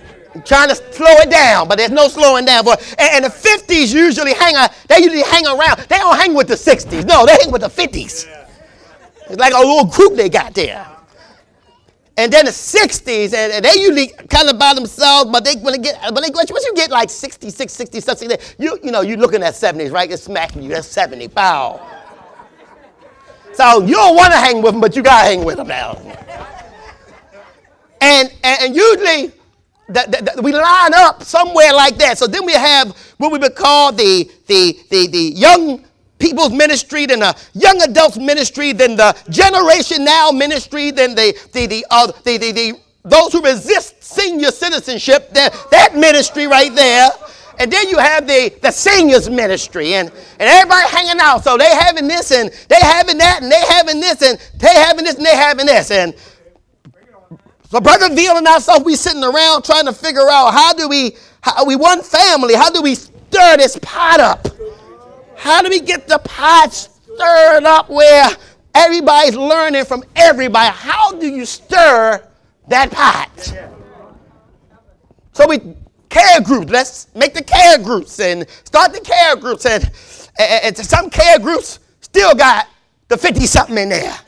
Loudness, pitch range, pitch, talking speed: -10 LUFS, 255-335 Hz, 295 Hz, 190 wpm